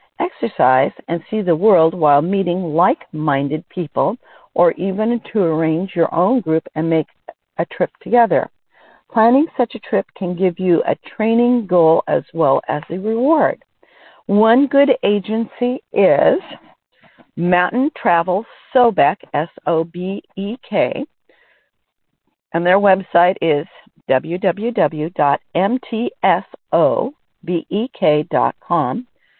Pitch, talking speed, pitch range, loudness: 185 Hz, 110 wpm, 165-230 Hz, -17 LUFS